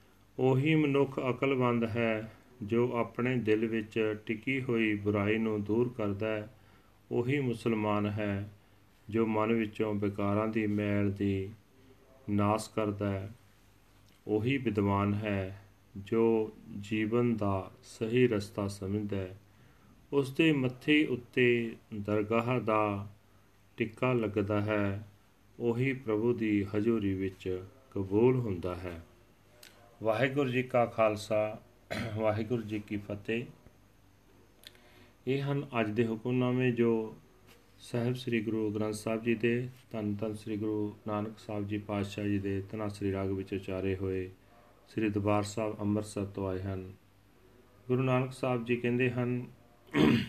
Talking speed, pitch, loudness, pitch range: 125 wpm, 110 Hz, -32 LUFS, 100-120 Hz